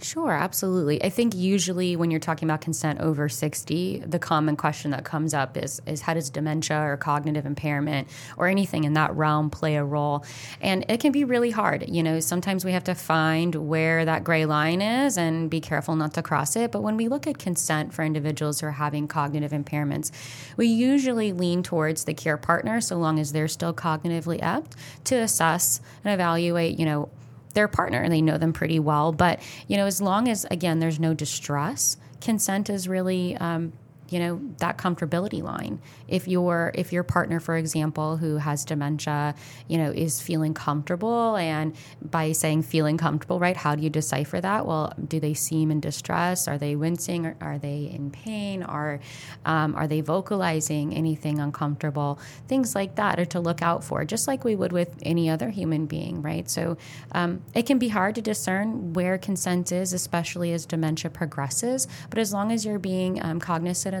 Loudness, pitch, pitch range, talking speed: -25 LUFS, 160 Hz, 150-180 Hz, 195 wpm